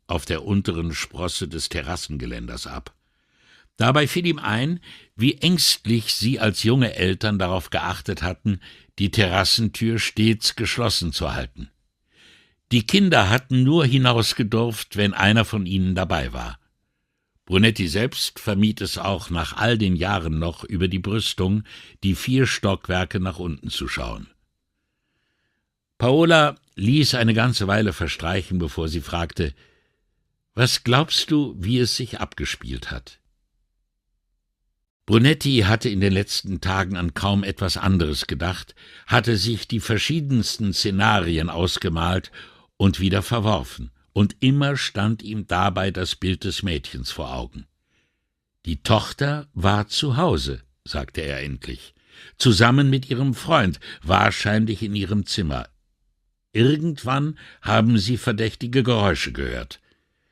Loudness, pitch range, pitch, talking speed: -21 LUFS, 85-115 Hz, 100 Hz, 125 wpm